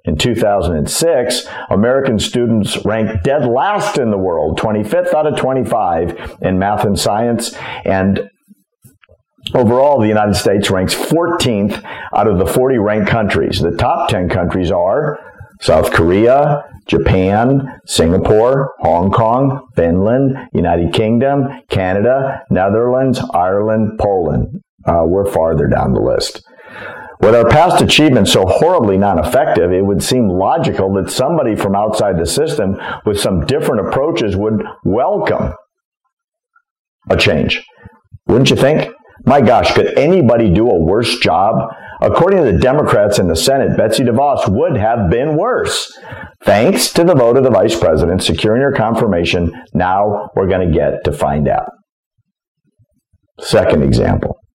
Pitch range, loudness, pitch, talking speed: 95-135 Hz, -13 LUFS, 110 Hz, 140 wpm